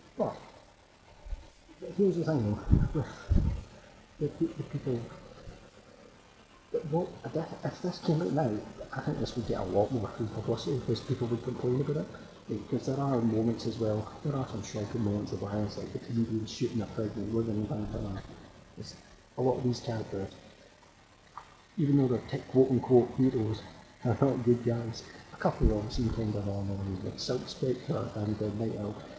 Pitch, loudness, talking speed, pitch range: 115 Hz, -32 LUFS, 165 wpm, 105-130 Hz